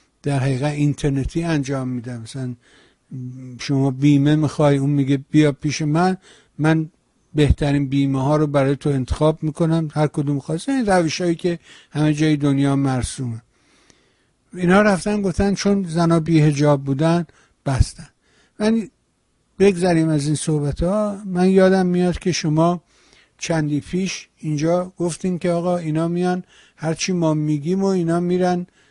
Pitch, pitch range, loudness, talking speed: 155 Hz, 145-180 Hz, -19 LUFS, 140 wpm